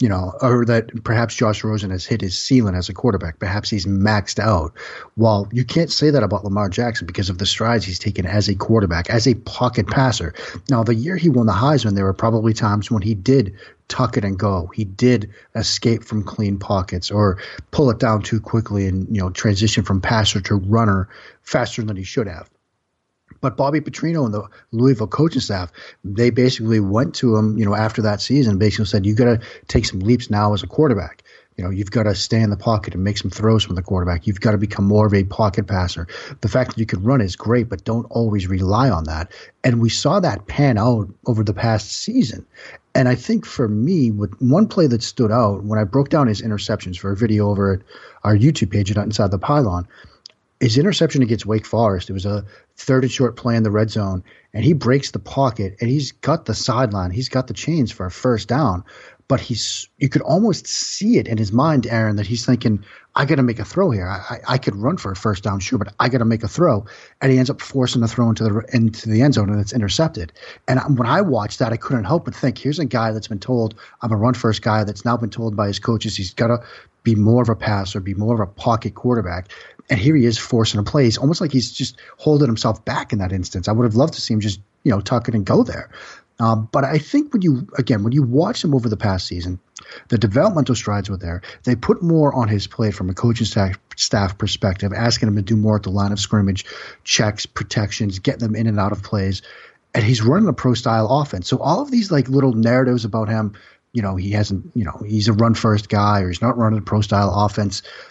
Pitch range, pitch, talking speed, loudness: 105-125 Hz, 110 Hz, 245 wpm, -19 LUFS